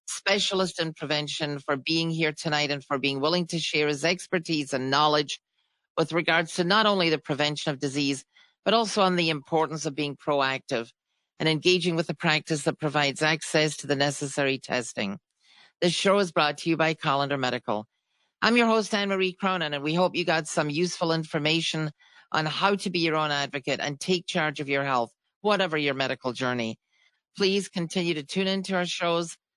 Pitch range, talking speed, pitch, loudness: 145-180 Hz, 190 wpm, 160 Hz, -26 LUFS